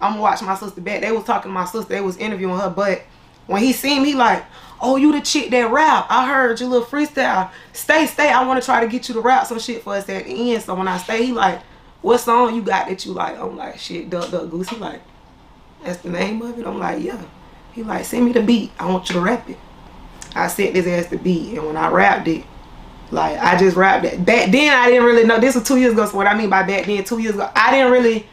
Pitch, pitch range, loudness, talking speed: 225 Hz, 185-245 Hz, -17 LUFS, 275 wpm